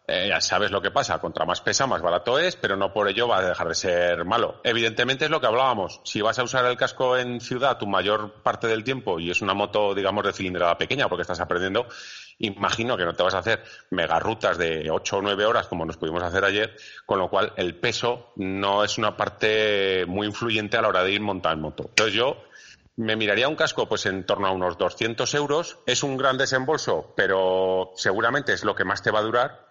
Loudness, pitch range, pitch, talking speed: -24 LUFS, 95-125 Hz, 105 Hz, 230 wpm